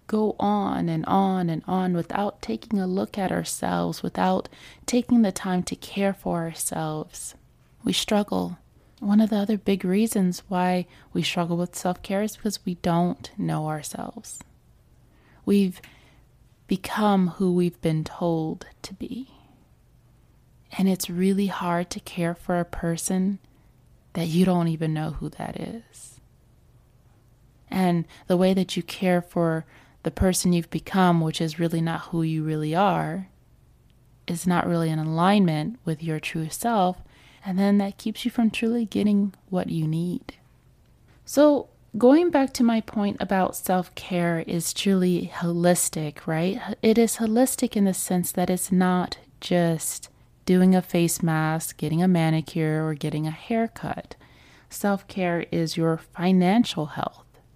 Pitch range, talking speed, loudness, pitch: 160-200 Hz, 150 wpm, -24 LUFS, 180 Hz